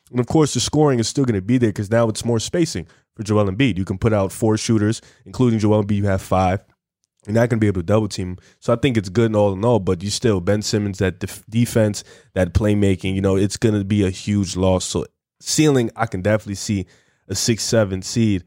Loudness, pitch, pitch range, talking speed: -19 LUFS, 105 Hz, 95-115 Hz, 245 wpm